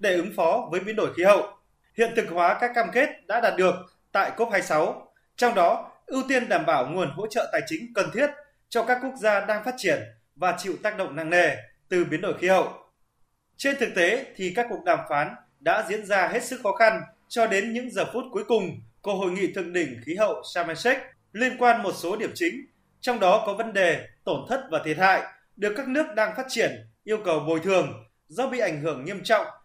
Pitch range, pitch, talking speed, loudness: 180-245 Hz, 210 Hz, 230 wpm, -25 LUFS